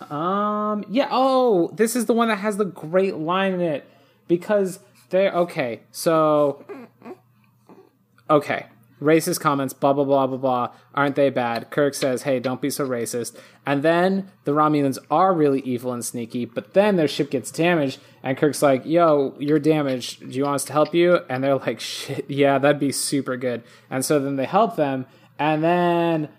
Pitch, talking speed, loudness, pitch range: 145 Hz, 185 wpm, -21 LUFS, 135-175 Hz